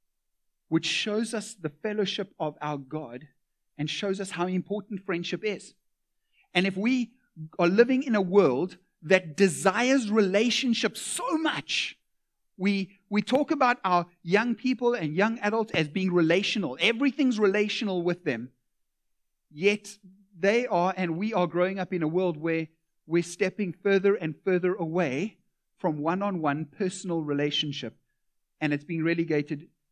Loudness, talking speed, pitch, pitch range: -27 LUFS, 140 wpm, 185 Hz, 165-210 Hz